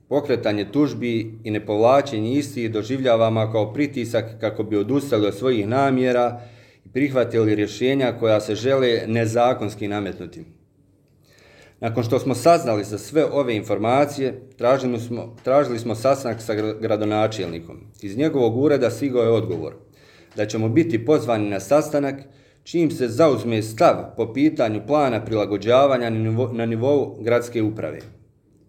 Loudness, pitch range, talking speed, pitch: -21 LUFS, 110-135 Hz, 130 wpm, 115 Hz